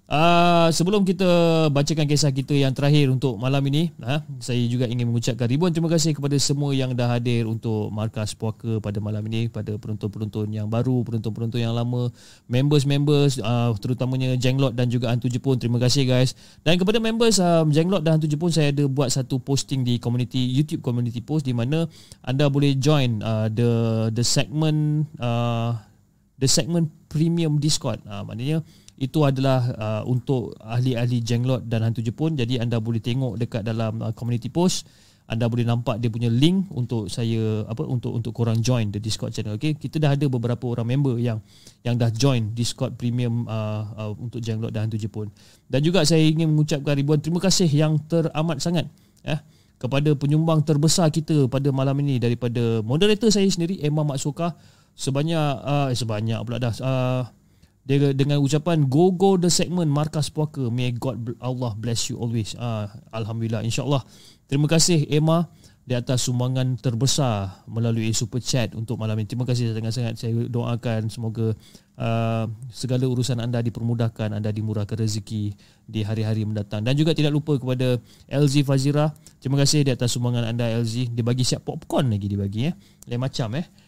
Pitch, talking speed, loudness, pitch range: 125 Hz, 175 wpm, -23 LUFS, 115-150 Hz